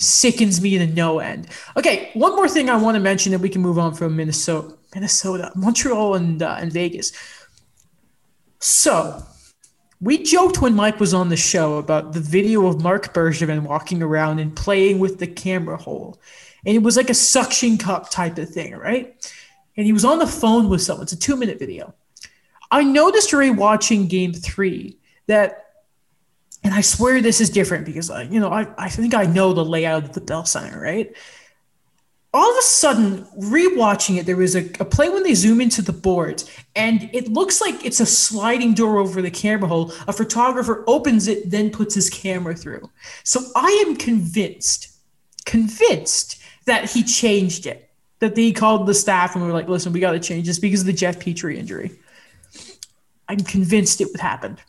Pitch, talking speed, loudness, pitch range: 205 Hz, 190 wpm, -18 LUFS, 180-230 Hz